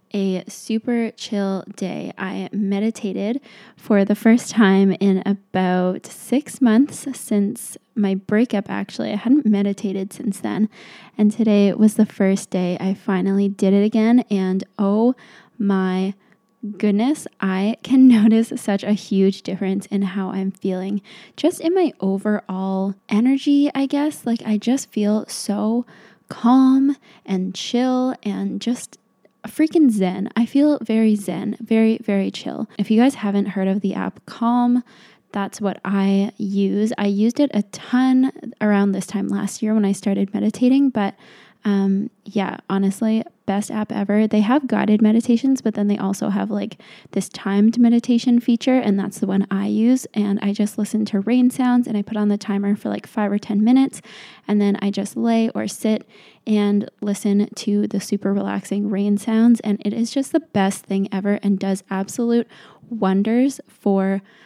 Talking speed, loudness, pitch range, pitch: 165 wpm, -20 LUFS, 200-230 Hz, 210 Hz